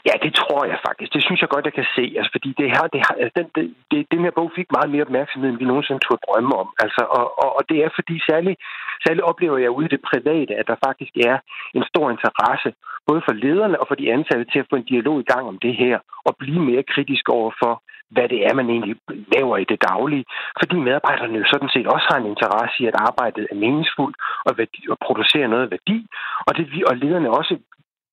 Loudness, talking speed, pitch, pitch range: -19 LUFS, 240 wpm, 140 Hz, 125-160 Hz